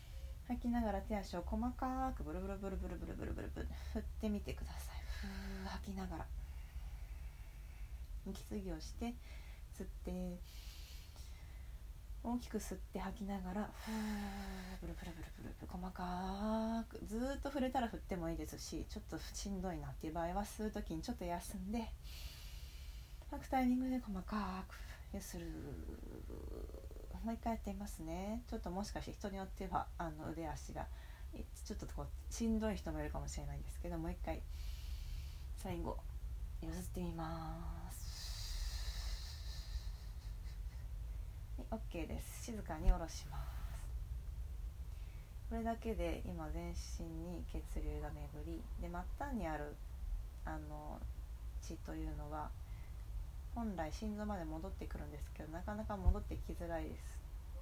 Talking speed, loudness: 295 characters per minute, -46 LUFS